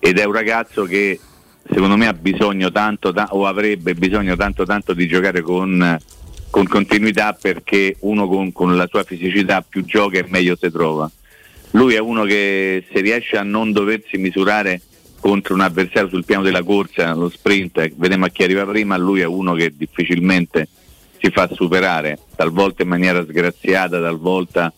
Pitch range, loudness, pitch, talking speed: 90-100 Hz, -16 LUFS, 95 Hz, 170 wpm